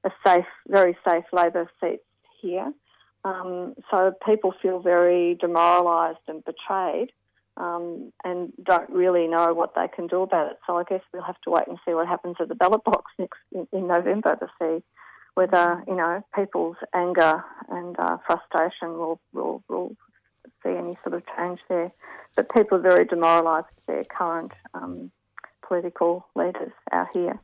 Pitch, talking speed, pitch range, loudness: 175 Hz, 165 wpm, 170-185 Hz, -24 LUFS